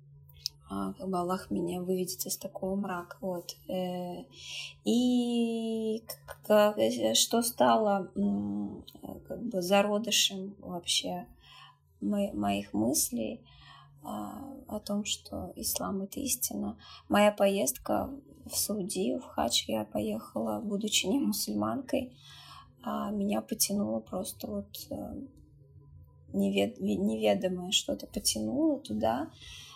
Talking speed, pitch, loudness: 90 wpm, 185 Hz, -31 LUFS